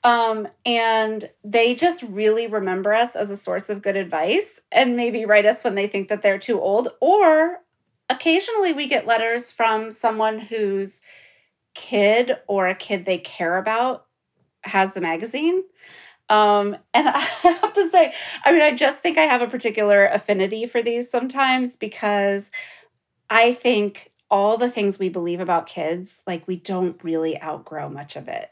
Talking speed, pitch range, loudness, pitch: 165 wpm, 200-255 Hz, -20 LUFS, 220 Hz